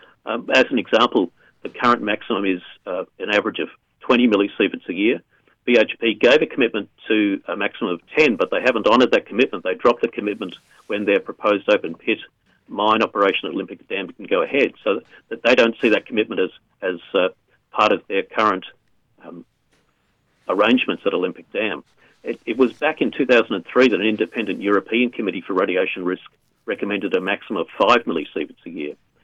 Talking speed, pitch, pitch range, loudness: 185 wpm, 100 Hz, 95-110 Hz, -20 LUFS